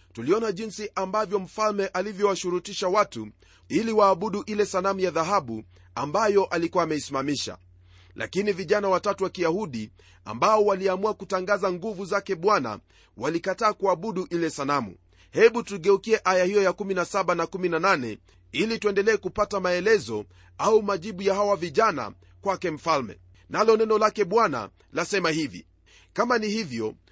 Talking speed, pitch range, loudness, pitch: 125 wpm, 140-210 Hz, -25 LUFS, 190 Hz